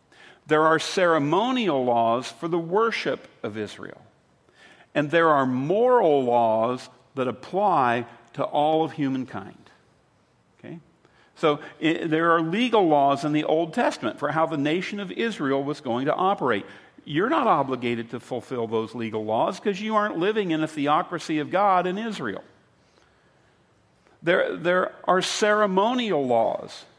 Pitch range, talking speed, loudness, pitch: 130-180 Hz, 145 wpm, -23 LUFS, 155 Hz